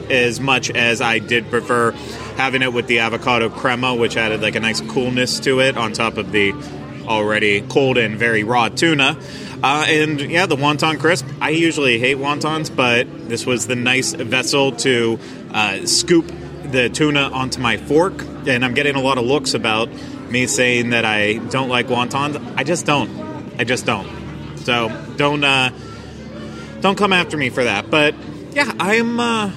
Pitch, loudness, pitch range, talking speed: 125 Hz, -17 LUFS, 115-145 Hz, 180 wpm